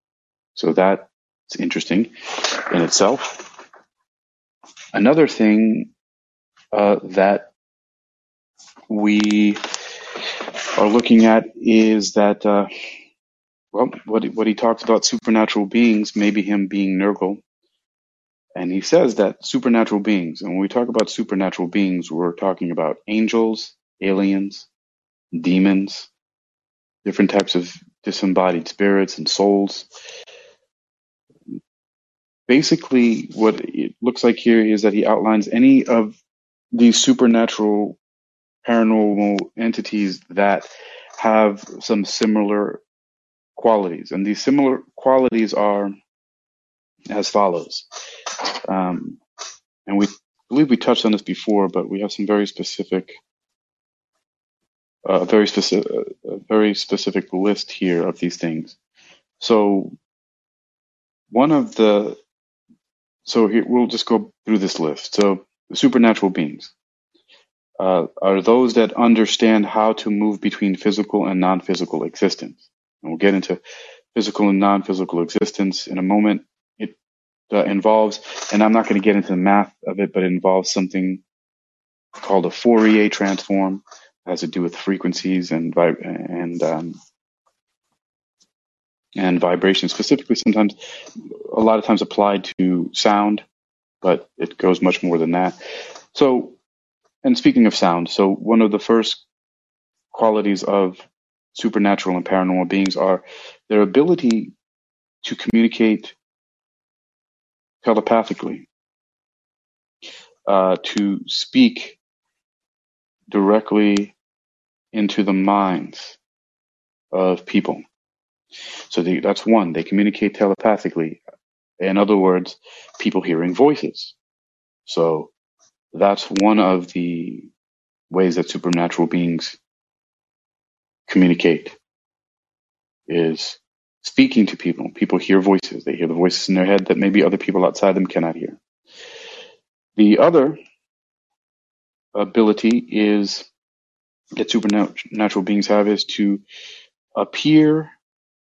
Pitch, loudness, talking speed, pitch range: 100 Hz, -18 LUFS, 115 wpm, 95-110 Hz